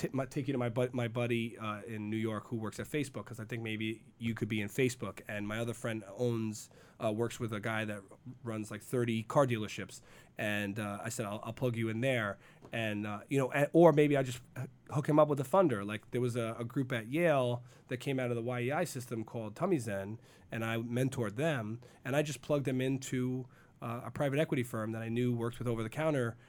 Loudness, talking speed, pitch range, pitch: -35 LUFS, 245 wpm, 110-130 Hz, 120 Hz